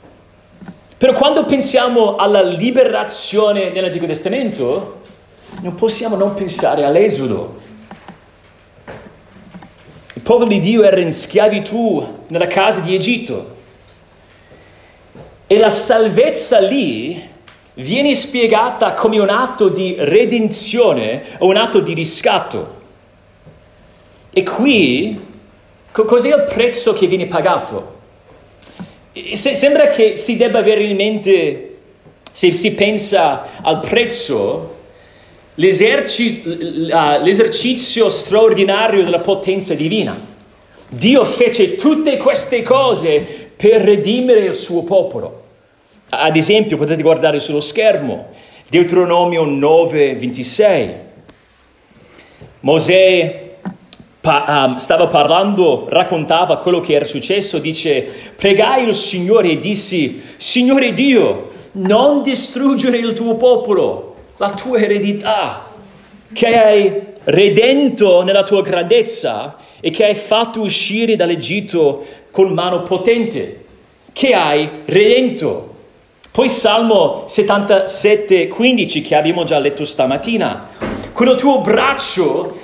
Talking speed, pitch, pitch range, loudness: 100 wpm, 210 Hz, 185-250 Hz, -13 LUFS